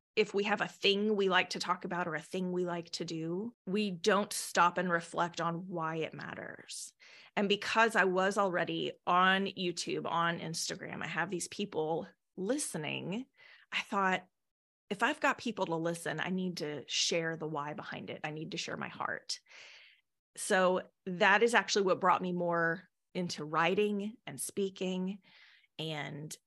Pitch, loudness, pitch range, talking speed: 180 Hz, -33 LUFS, 170-200 Hz, 170 wpm